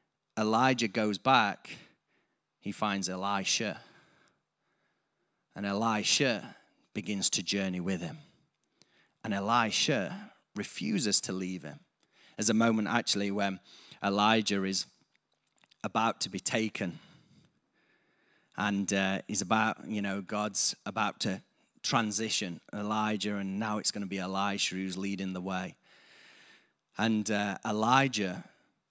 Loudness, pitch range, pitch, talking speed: -31 LUFS, 95-110 Hz, 100 Hz, 110 wpm